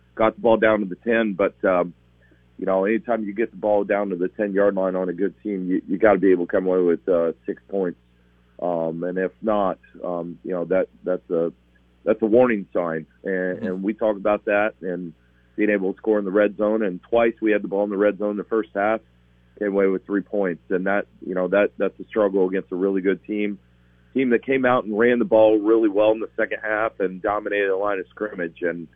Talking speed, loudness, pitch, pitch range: 250 wpm, -22 LUFS, 100 Hz, 85-105 Hz